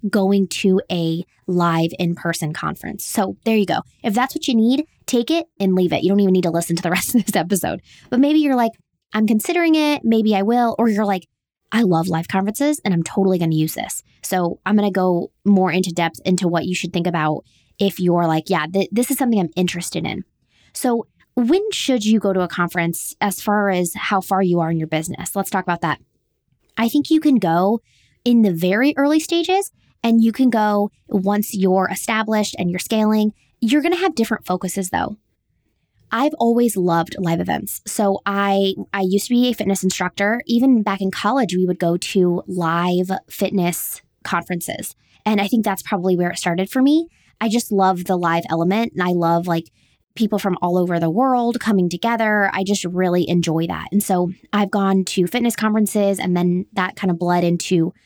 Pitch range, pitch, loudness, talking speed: 175-225 Hz, 195 Hz, -19 LUFS, 210 wpm